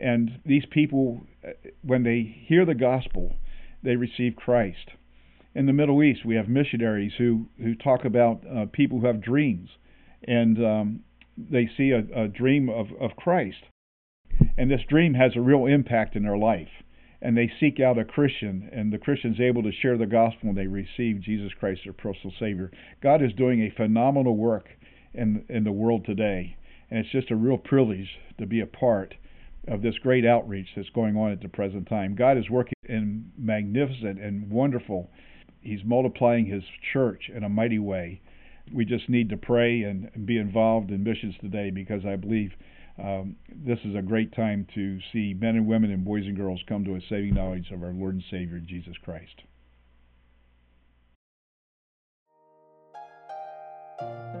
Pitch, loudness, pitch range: 110 Hz, -25 LUFS, 95-120 Hz